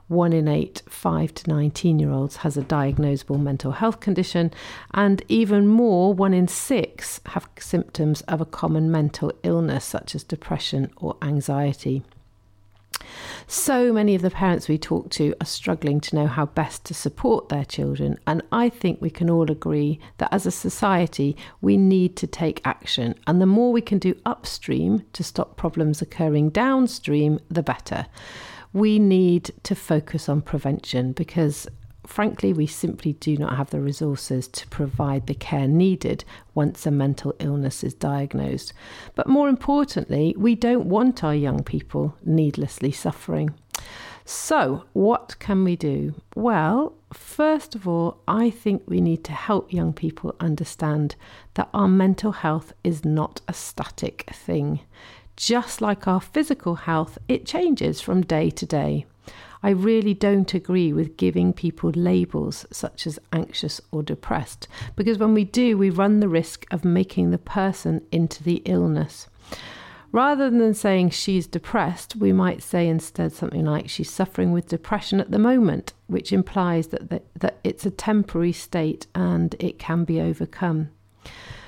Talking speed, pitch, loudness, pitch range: 160 wpm, 160 Hz, -23 LUFS, 140-190 Hz